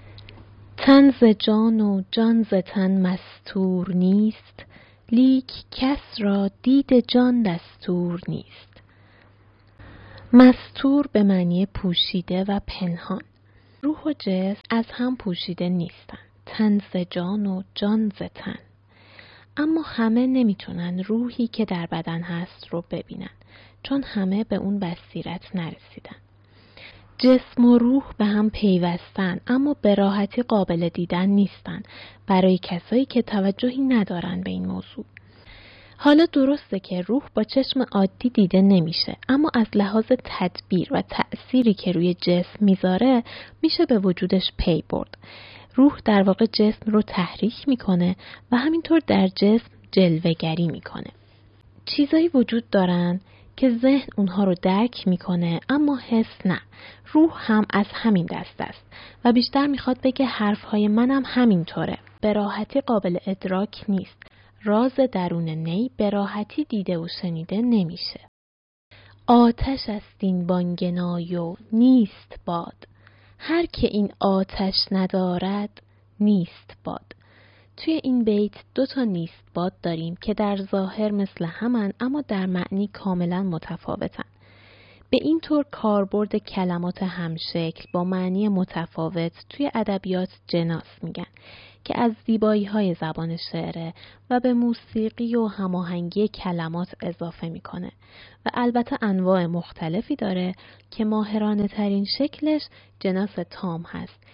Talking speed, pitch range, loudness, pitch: 125 wpm, 175-230 Hz, -22 LUFS, 195 Hz